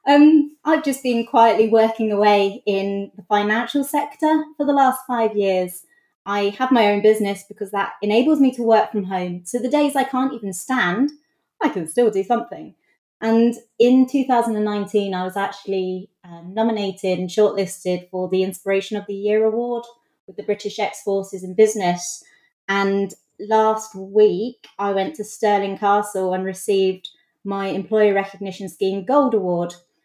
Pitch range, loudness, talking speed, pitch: 195-235 Hz, -20 LUFS, 160 wpm, 210 Hz